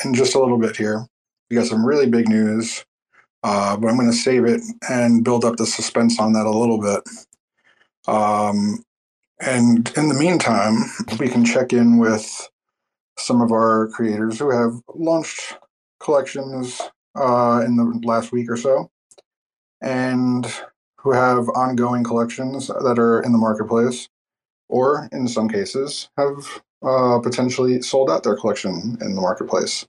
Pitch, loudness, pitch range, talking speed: 120 Hz, -19 LUFS, 115-130 Hz, 155 wpm